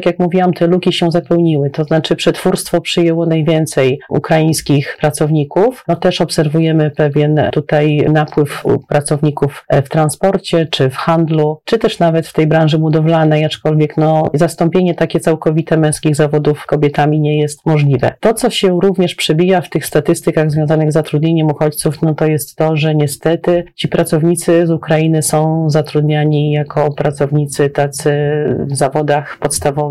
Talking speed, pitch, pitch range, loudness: 150 wpm, 155 Hz, 150-170 Hz, -13 LUFS